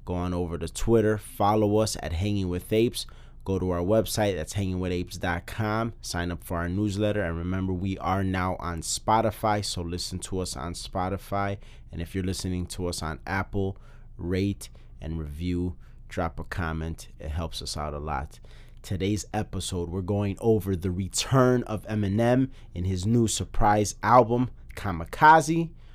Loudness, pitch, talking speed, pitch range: -27 LUFS, 95 Hz, 160 wpm, 90-105 Hz